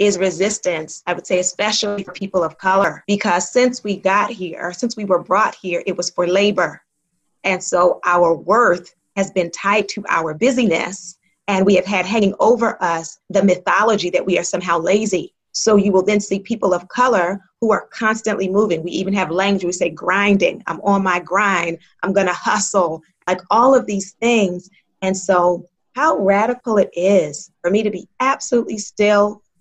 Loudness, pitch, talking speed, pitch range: -17 LUFS, 190 Hz, 185 wpm, 180-205 Hz